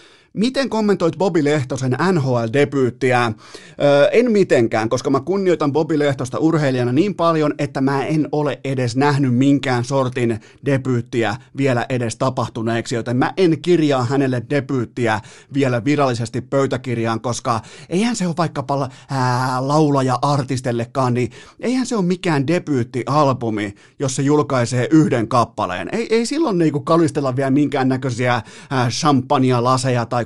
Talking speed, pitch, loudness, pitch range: 125 wpm, 135 Hz, -18 LUFS, 125-150 Hz